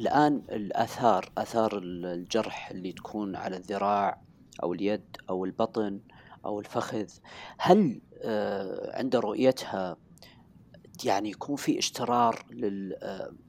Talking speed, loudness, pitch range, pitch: 95 wpm, -30 LUFS, 95-115 Hz, 105 Hz